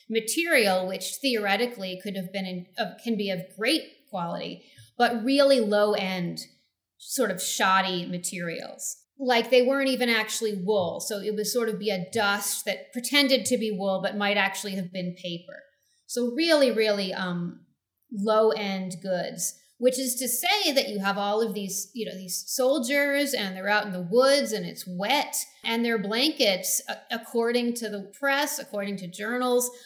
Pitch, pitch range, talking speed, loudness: 215 Hz, 190-250 Hz, 170 wpm, -26 LUFS